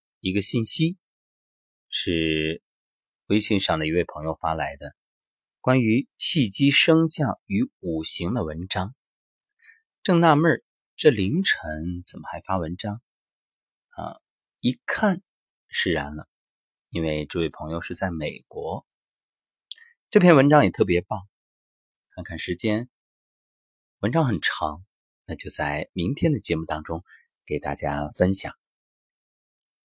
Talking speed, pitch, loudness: 175 characters per minute, 100 Hz, -23 LUFS